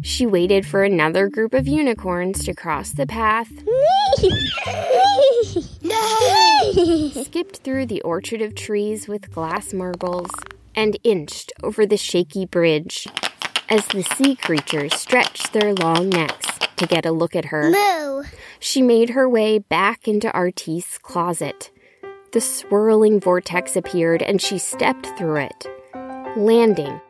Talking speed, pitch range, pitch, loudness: 130 wpm, 175-260 Hz, 210 Hz, -19 LUFS